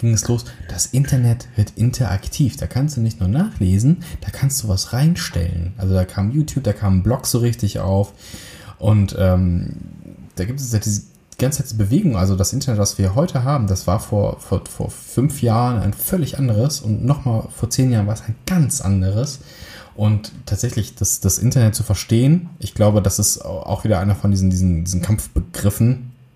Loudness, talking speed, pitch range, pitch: -19 LUFS, 195 wpm, 100-130 Hz, 110 Hz